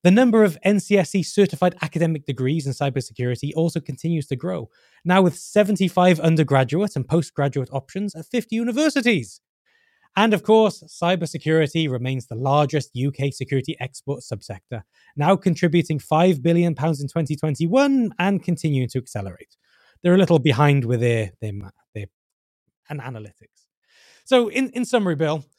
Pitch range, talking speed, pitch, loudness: 135-185 Hz, 140 wpm, 160 Hz, -21 LUFS